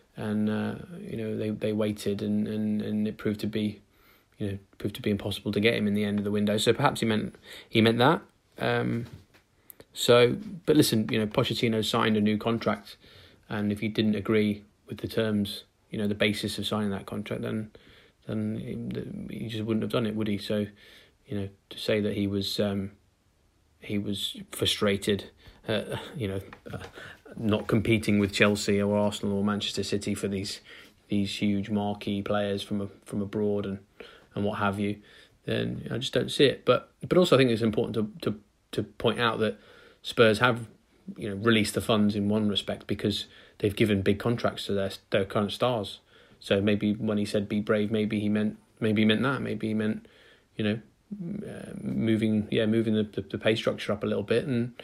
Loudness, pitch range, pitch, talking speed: -28 LUFS, 100-110 Hz, 105 Hz, 205 wpm